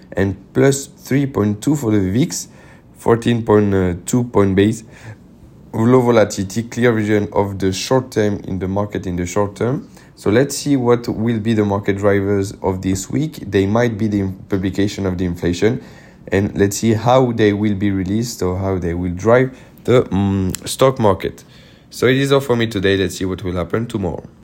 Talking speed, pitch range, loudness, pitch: 180 wpm, 95-120 Hz, -17 LUFS, 105 Hz